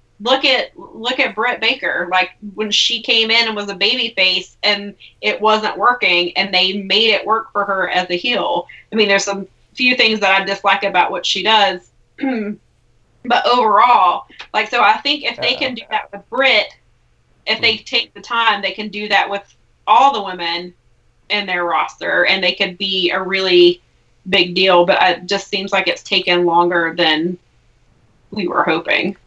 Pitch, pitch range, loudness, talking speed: 200 Hz, 185-225 Hz, -15 LUFS, 190 wpm